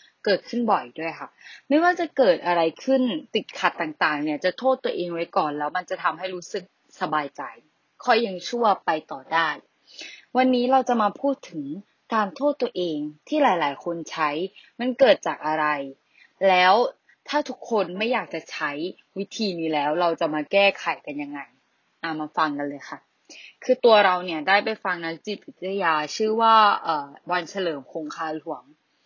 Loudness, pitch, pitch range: -23 LUFS, 185 Hz, 160-235 Hz